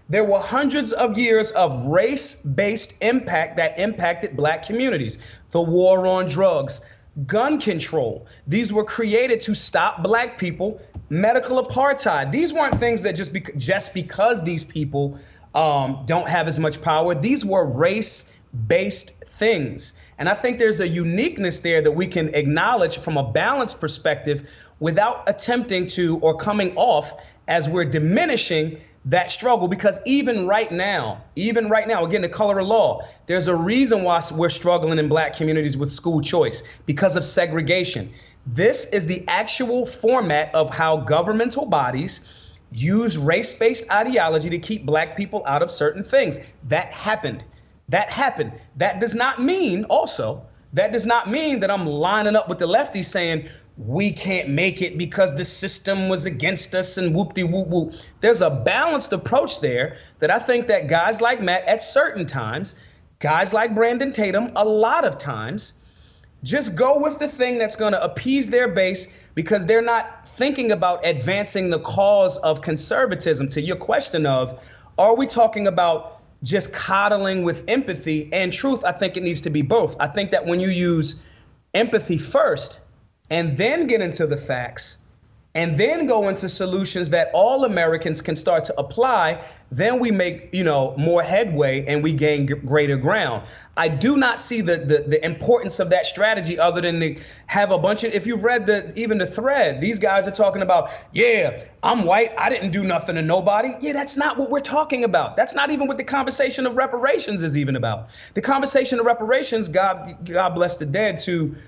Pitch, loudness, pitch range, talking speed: 185 Hz, -20 LUFS, 160-225 Hz, 175 wpm